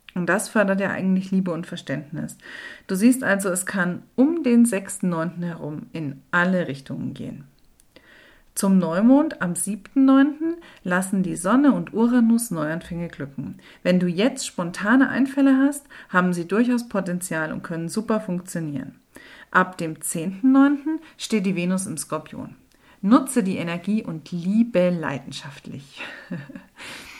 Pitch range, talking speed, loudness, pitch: 175-240 Hz, 130 wpm, -22 LUFS, 190 Hz